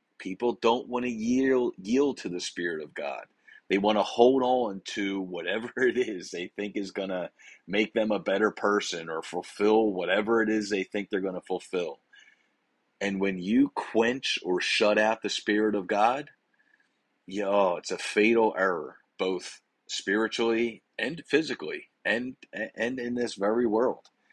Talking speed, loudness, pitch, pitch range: 165 wpm, -28 LUFS, 110 Hz, 100-120 Hz